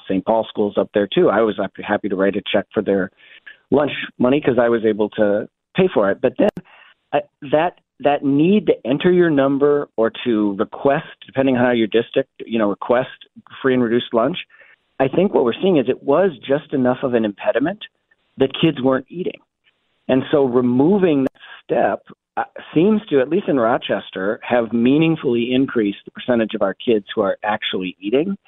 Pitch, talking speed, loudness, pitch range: 125 Hz, 190 wpm, -18 LUFS, 110-140 Hz